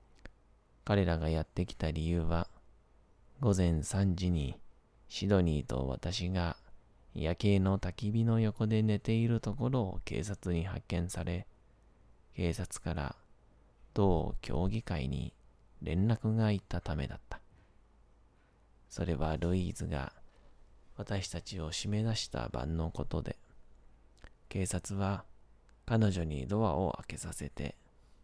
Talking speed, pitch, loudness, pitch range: 215 characters per minute, 90 Hz, -34 LUFS, 80-105 Hz